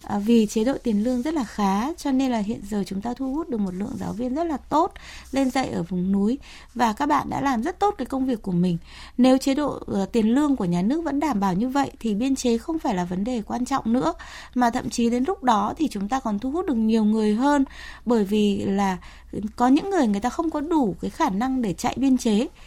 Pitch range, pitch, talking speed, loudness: 215-275 Hz, 245 Hz, 265 wpm, -23 LUFS